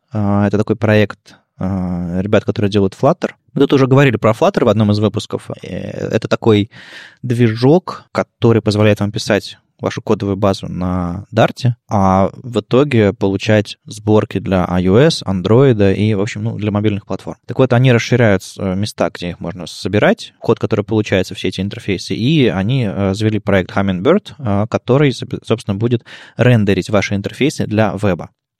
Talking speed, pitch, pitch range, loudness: 150 wpm, 105 Hz, 100-120 Hz, -15 LUFS